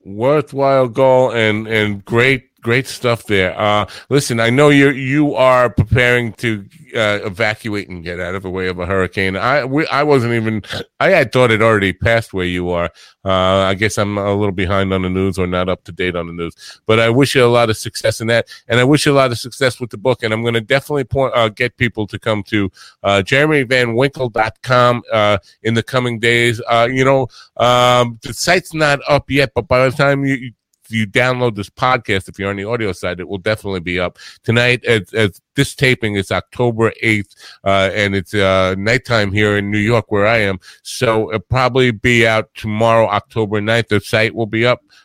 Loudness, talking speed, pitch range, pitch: -15 LUFS, 215 wpm, 100-125 Hz, 115 Hz